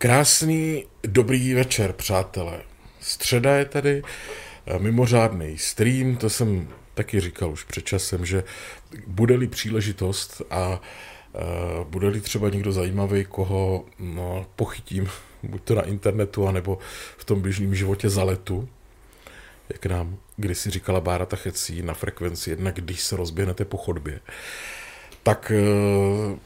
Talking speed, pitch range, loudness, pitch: 125 wpm, 90-110 Hz, -24 LUFS, 100 Hz